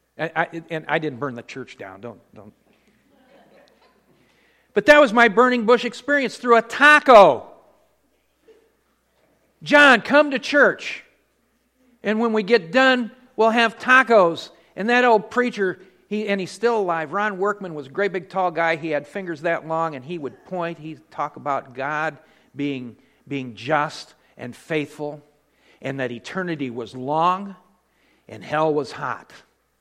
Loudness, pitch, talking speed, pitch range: -19 LUFS, 185 Hz, 155 wpm, 155-235 Hz